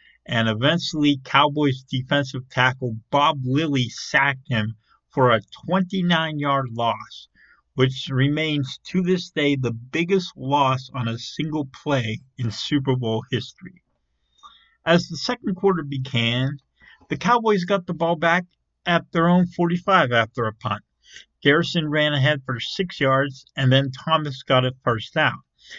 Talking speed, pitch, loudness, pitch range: 140 wpm, 140 Hz, -22 LUFS, 130-165 Hz